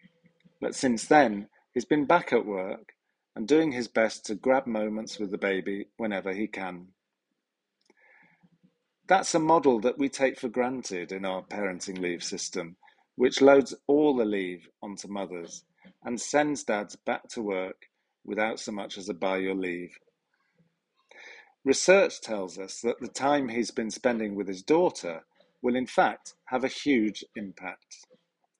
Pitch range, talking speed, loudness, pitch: 95-140 Hz, 155 wpm, -28 LUFS, 110 Hz